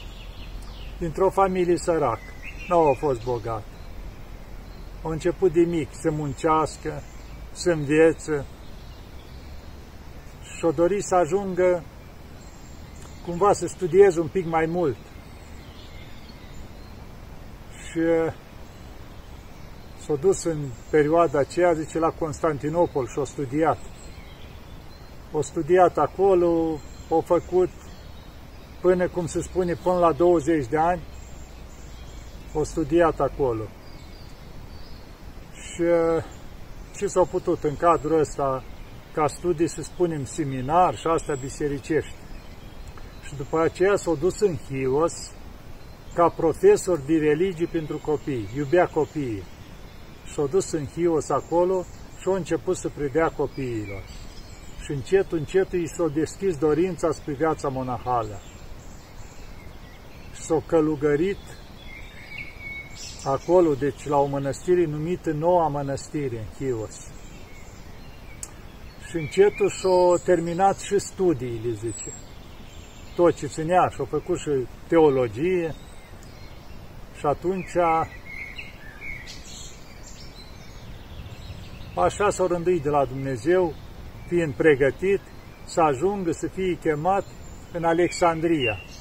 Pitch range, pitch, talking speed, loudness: 115-175 Hz, 155 Hz, 105 wpm, -24 LUFS